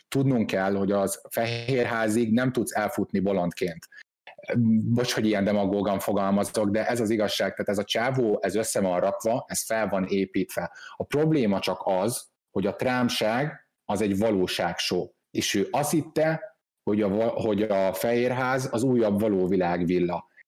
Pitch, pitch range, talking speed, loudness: 110 Hz, 100-125 Hz, 155 wpm, -26 LUFS